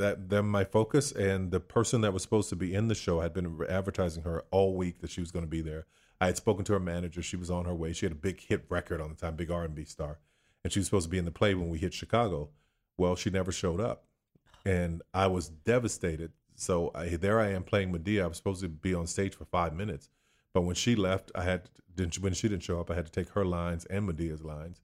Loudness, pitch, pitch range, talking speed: -32 LUFS, 90 Hz, 85-100 Hz, 270 wpm